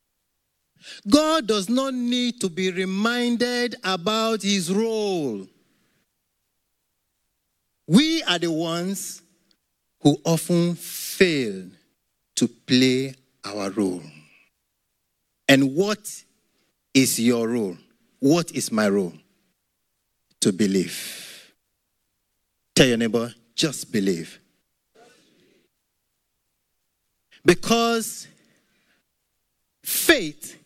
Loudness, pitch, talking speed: -22 LUFS, 165 Hz, 75 wpm